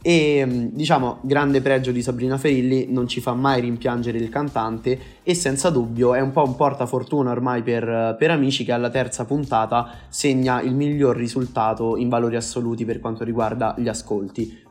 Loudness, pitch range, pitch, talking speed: -21 LUFS, 115-135 Hz, 125 Hz, 170 wpm